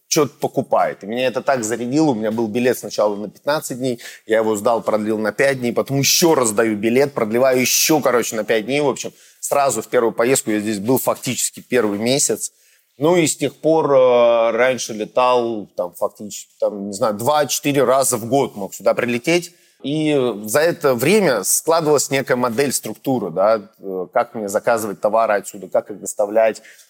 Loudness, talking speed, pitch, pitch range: -18 LUFS, 180 wpm, 125 Hz, 110-140 Hz